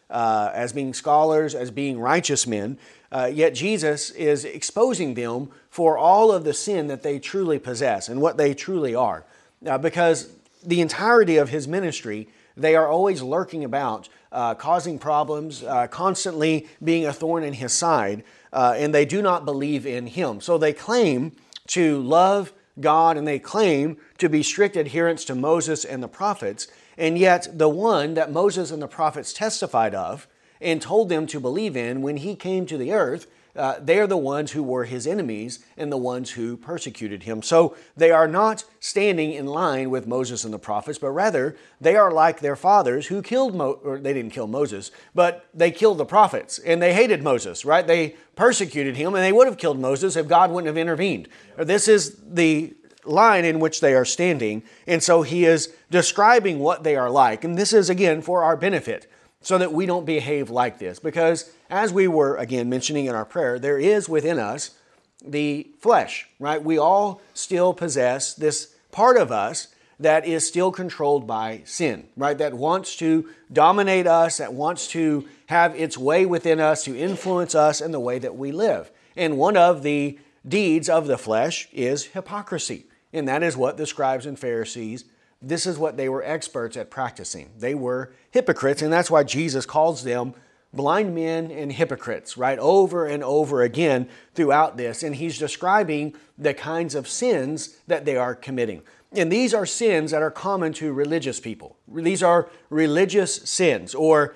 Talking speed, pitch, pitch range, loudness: 185 wpm, 155 Hz, 140-175 Hz, -21 LUFS